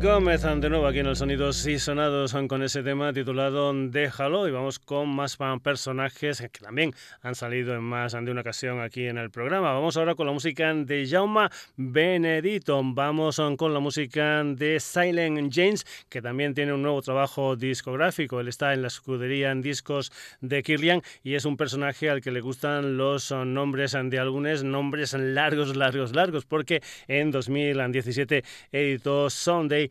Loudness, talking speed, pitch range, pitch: -26 LUFS, 175 wpm, 135-150 Hz, 140 Hz